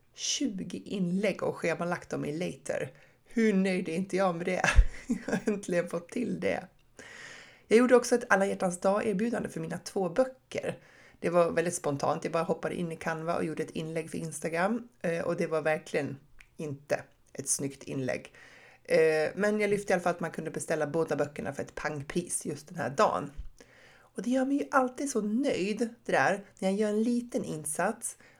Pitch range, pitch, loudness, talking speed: 160-215 Hz, 185 Hz, -30 LUFS, 190 wpm